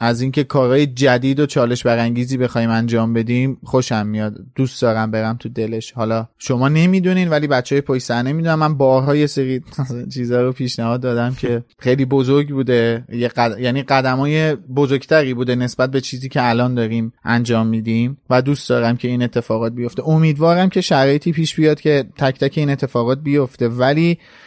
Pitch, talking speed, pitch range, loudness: 130 Hz, 170 wpm, 120-140 Hz, -17 LUFS